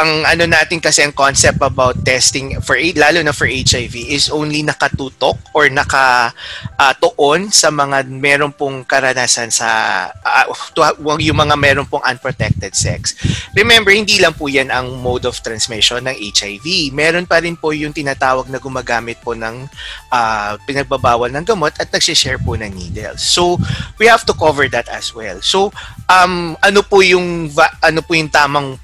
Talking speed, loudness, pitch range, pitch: 165 wpm, -13 LUFS, 125-160 Hz, 140 Hz